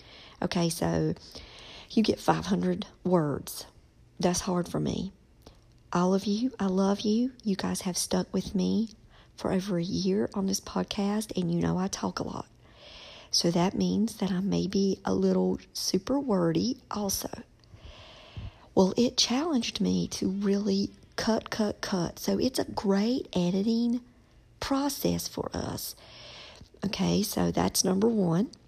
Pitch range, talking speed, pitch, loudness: 170-210 Hz, 145 wpm, 190 Hz, -29 LUFS